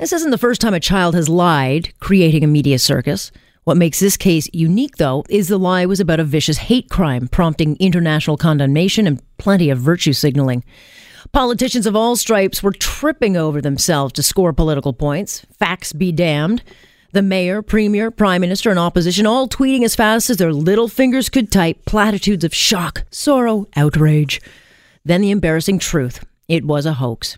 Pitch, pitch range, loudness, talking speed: 175 Hz, 155-210 Hz, -15 LUFS, 180 wpm